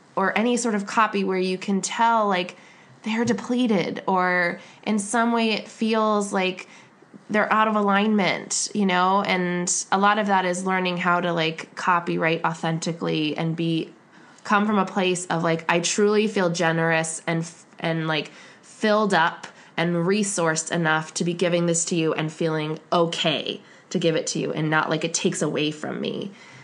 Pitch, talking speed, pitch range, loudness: 180 Hz, 180 wpm, 165-205 Hz, -23 LUFS